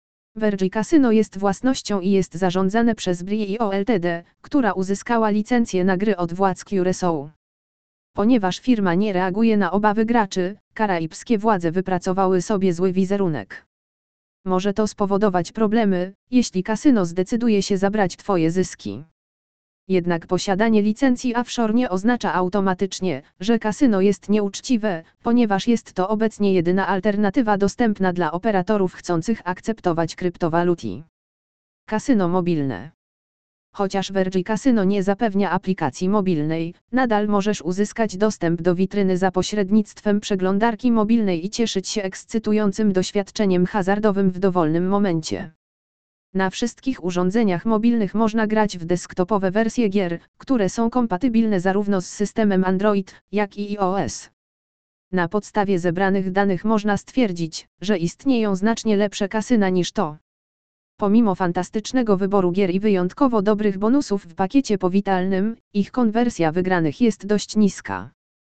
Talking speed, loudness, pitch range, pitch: 125 wpm, -21 LUFS, 185-220 Hz, 200 Hz